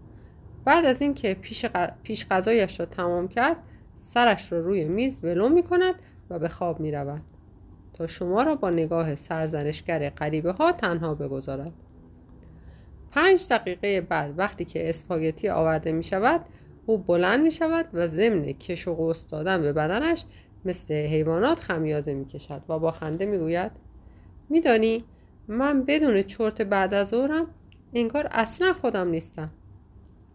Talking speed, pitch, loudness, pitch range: 145 wpm, 175 Hz, -25 LUFS, 155-225 Hz